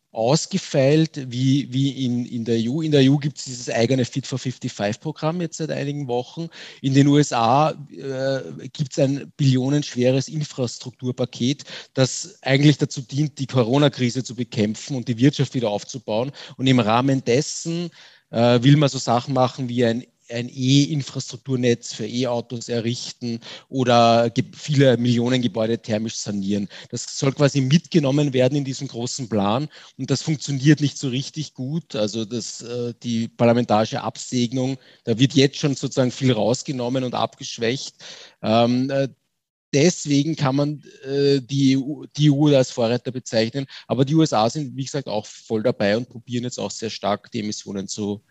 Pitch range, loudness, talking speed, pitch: 120-145 Hz, -21 LUFS, 155 wpm, 130 Hz